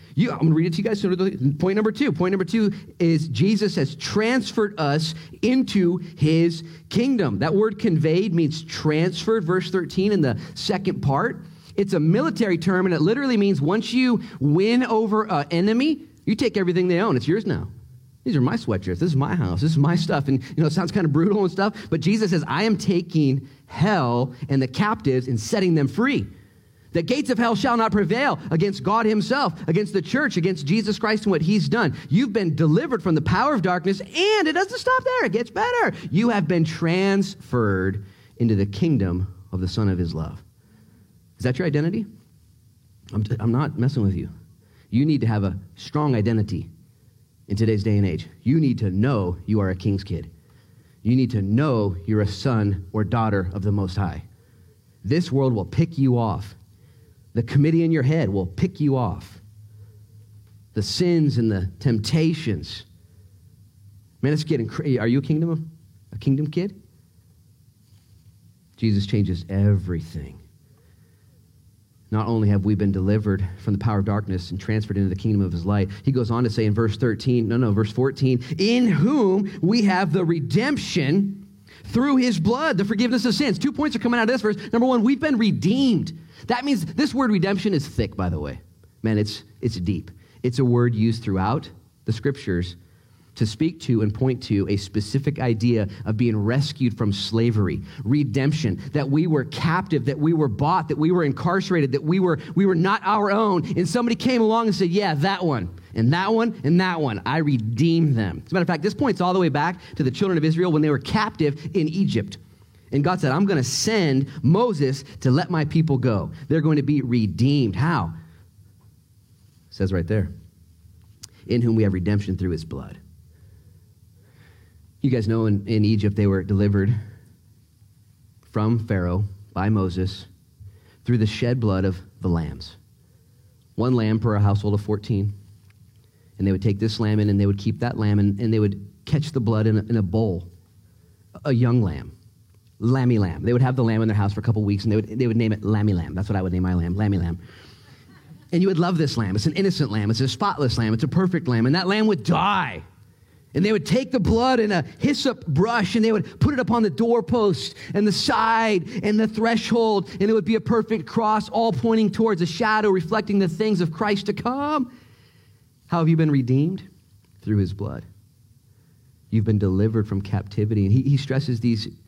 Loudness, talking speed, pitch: -22 LUFS, 200 wpm, 130 Hz